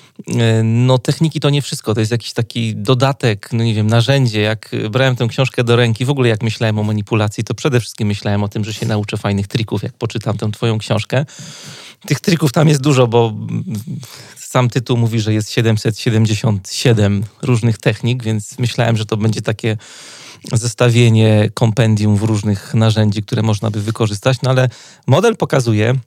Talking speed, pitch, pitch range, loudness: 175 wpm, 115 Hz, 110-130 Hz, -16 LUFS